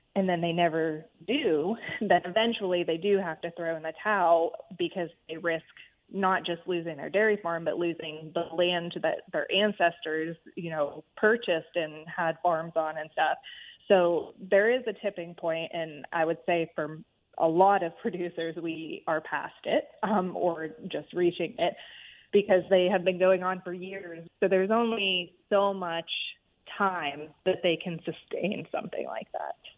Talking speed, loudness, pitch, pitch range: 170 wpm, -29 LUFS, 175 Hz, 165-195 Hz